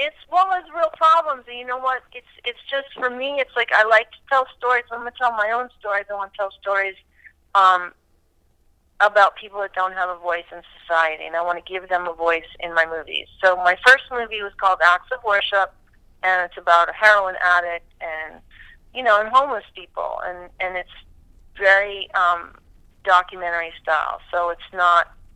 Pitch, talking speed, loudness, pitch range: 190 Hz, 195 wpm, -20 LUFS, 175-240 Hz